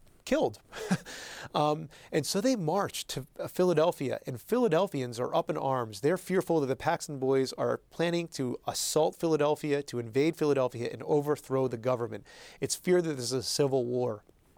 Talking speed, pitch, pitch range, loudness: 165 wpm, 145 Hz, 130-165 Hz, -30 LUFS